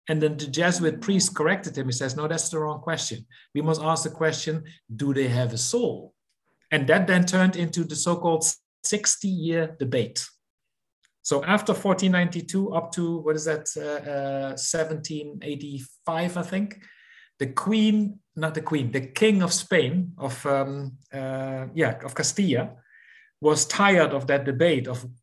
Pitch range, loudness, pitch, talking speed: 140-180 Hz, -25 LUFS, 160 Hz, 155 wpm